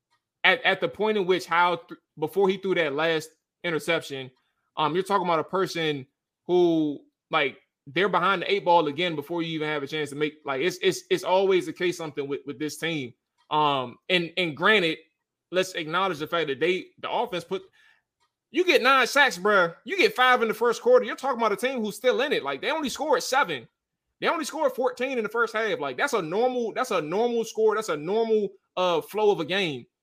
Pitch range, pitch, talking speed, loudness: 160-245 Hz, 190 Hz, 220 wpm, -25 LUFS